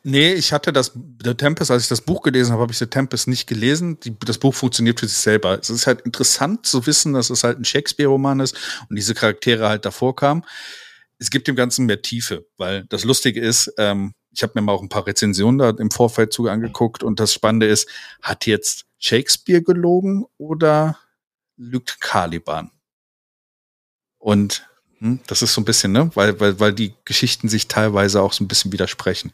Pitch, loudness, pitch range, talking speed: 120 Hz, -18 LUFS, 110-135 Hz, 200 wpm